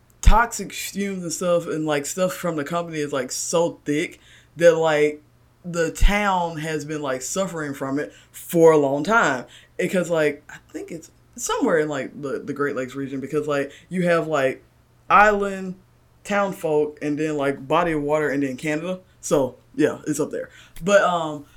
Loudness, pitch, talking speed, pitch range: -22 LUFS, 155 Hz, 180 wpm, 145-175 Hz